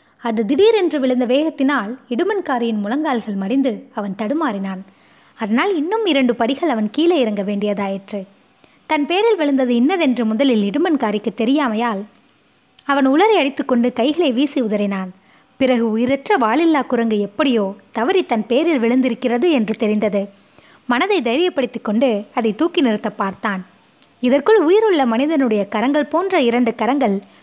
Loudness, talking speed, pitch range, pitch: -17 LUFS, 120 wpm, 220-300 Hz, 250 Hz